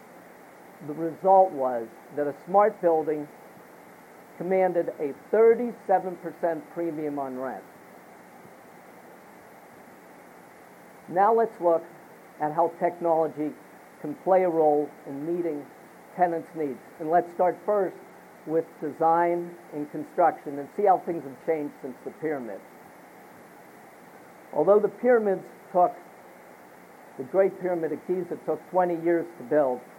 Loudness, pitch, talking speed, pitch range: -26 LUFS, 170 Hz, 115 wpm, 150-185 Hz